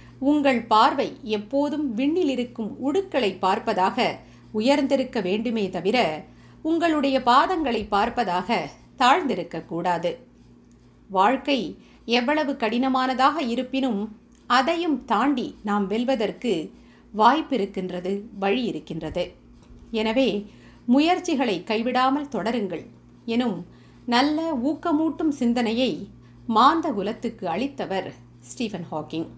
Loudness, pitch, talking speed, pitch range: -23 LUFS, 235 Hz, 75 wpm, 200-275 Hz